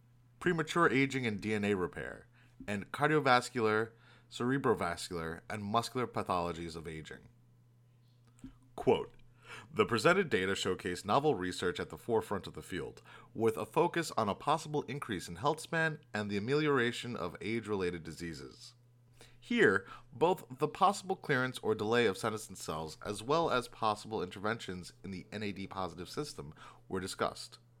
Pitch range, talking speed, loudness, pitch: 100-125 Hz, 140 wpm, -34 LUFS, 115 Hz